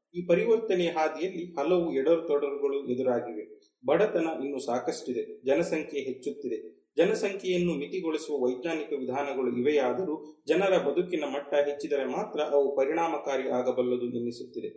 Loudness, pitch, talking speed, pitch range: -29 LUFS, 155 Hz, 105 wpm, 140-190 Hz